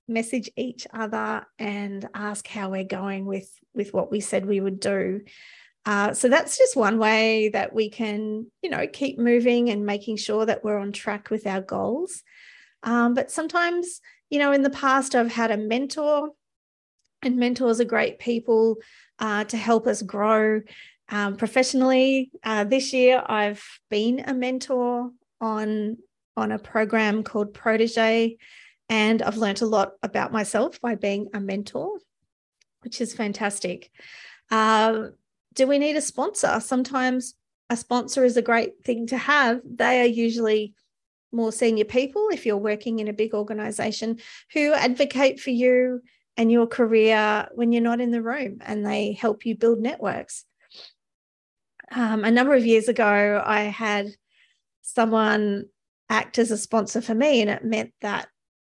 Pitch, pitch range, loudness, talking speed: 230 Hz, 210-250 Hz, -23 LUFS, 160 wpm